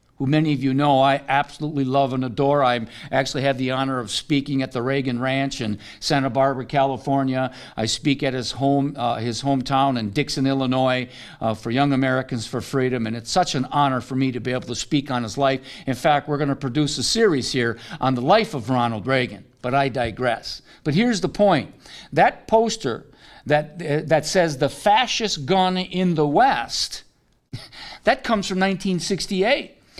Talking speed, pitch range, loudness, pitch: 190 wpm, 125-150 Hz, -21 LUFS, 135 Hz